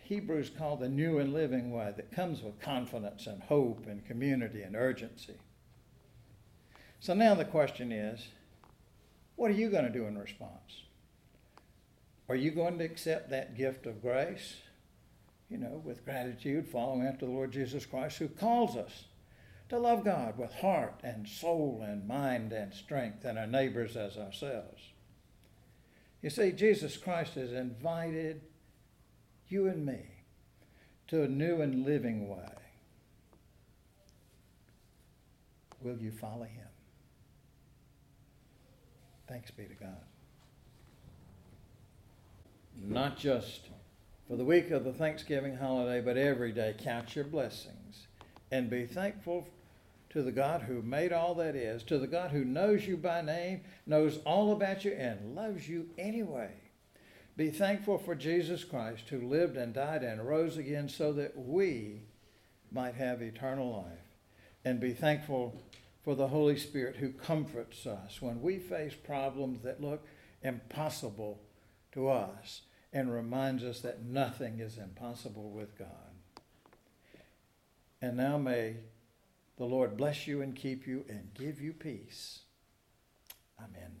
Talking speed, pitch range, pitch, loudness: 140 wpm, 110-150 Hz, 125 Hz, -35 LUFS